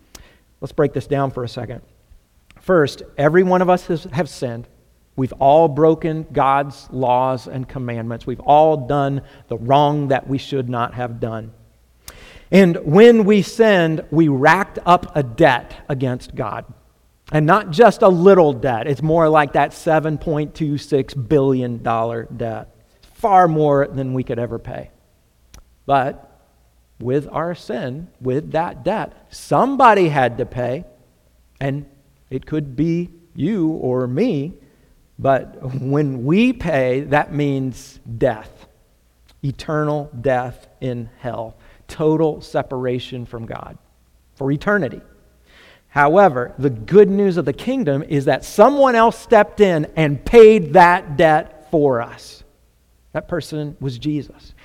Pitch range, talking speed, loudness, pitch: 125-160 Hz, 135 wpm, -17 LUFS, 140 Hz